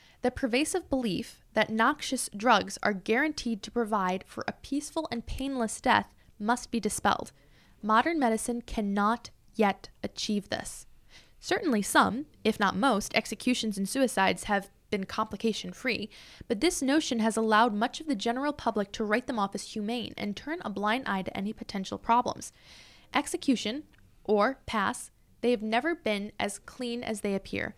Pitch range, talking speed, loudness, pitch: 210-260 Hz, 160 wpm, -29 LUFS, 230 Hz